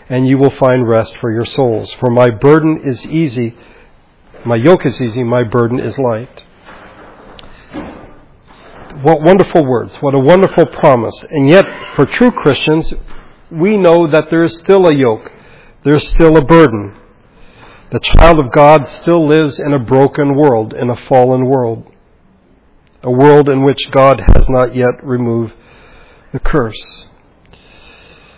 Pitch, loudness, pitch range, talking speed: 135 Hz, -10 LUFS, 120-155 Hz, 150 wpm